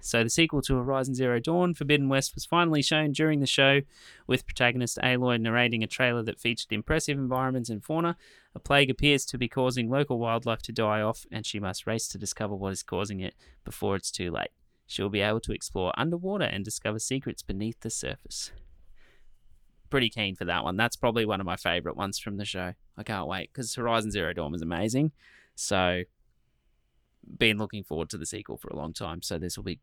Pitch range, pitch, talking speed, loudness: 100-130 Hz, 115 Hz, 205 wpm, -28 LUFS